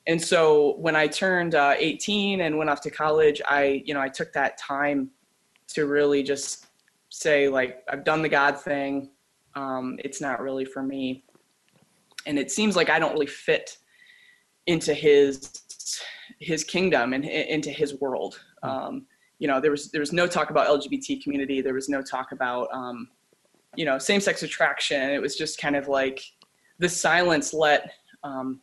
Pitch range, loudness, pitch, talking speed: 140-165 Hz, -24 LUFS, 145 Hz, 175 wpm